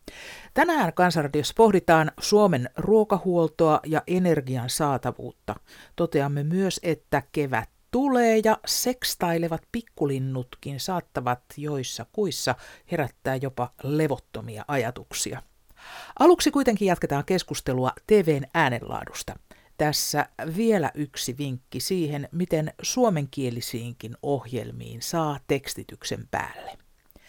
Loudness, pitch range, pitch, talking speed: -25 LUFS, 130-180 Hz, 150 Hz, 90 wpm